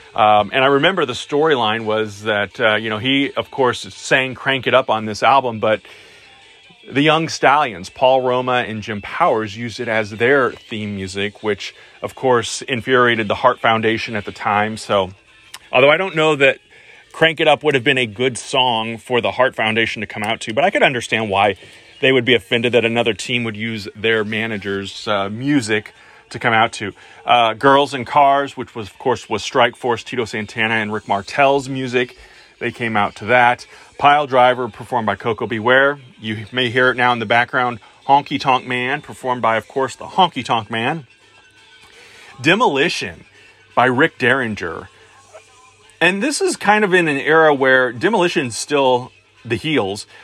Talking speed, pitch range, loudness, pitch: 185 wpm, 110-135 Hz, -17 LUFS, 120 Hz